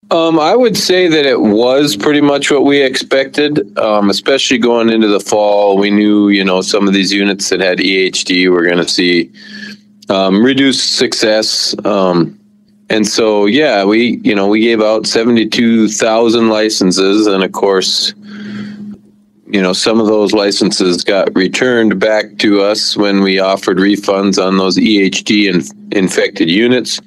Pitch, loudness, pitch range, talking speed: 110 Hz, -11 LUFS, 100-135 Hz, 160 wpm